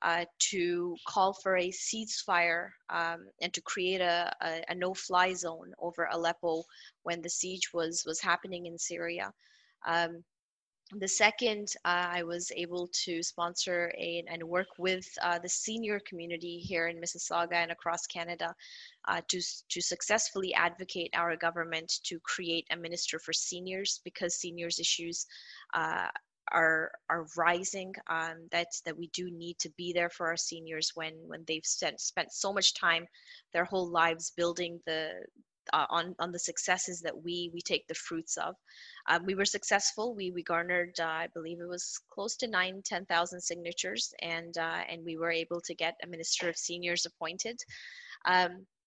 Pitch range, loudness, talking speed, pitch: 170-180 Hz, -33 LUFS, 170 wpm, 175 Hz